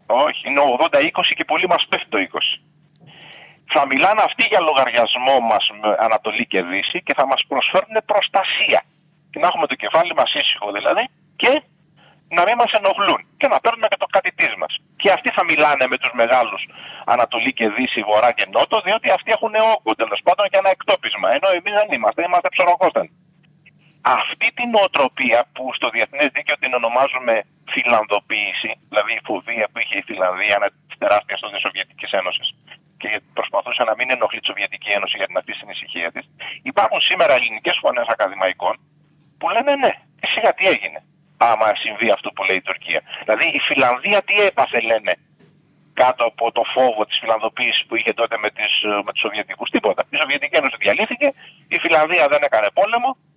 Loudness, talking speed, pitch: -18 LUFS, 175 wpm, 165 Hz